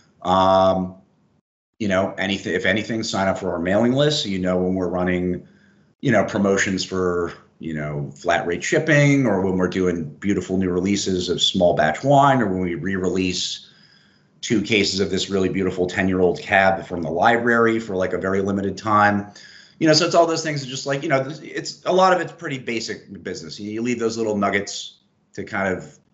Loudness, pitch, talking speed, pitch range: -20 LUFS, 95 Hz, 200 wpm, 90-115 Hz